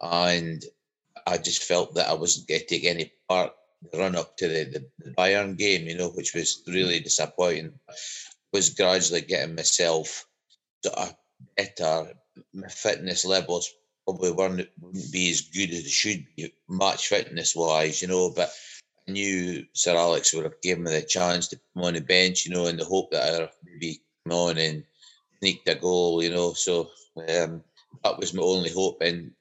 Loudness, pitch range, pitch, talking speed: -25 LUFS, 85-90 Hz, 90 Hz, 180 wpm